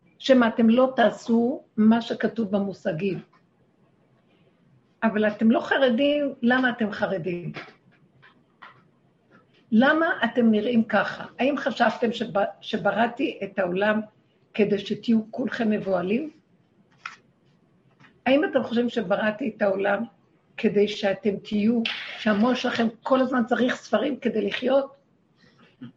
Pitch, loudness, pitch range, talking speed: 225 Hz, -24 LUFS, 210-250 Hz, 100 wpm